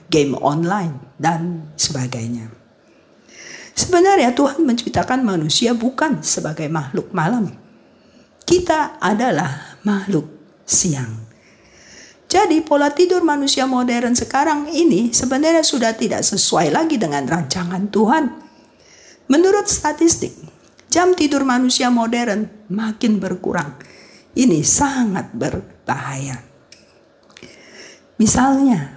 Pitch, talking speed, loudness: 235 Hz, 90 wpm, -17 LUFS